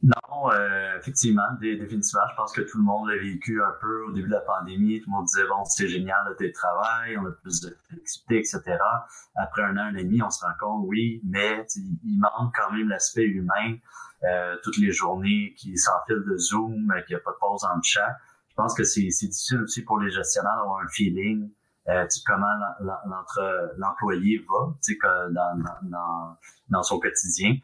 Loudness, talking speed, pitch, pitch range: -25 LUFS, 195 wpm, 105 Hz, 95-115 Hz